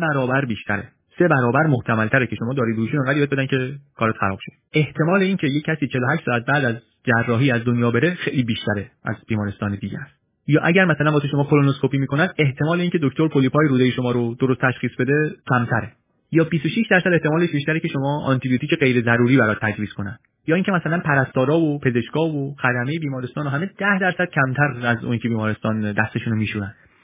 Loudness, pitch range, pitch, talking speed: -20 LUFS, 120-155 Hz, 135 Hz, 185 wpm